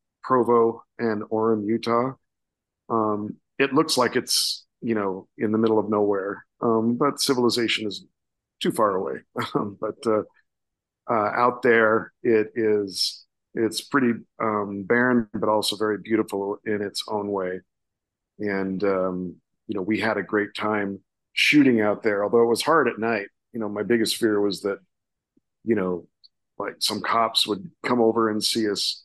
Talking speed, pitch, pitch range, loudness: 160 wpm, 110 Hz, 100-115 Hz, -23 LUFS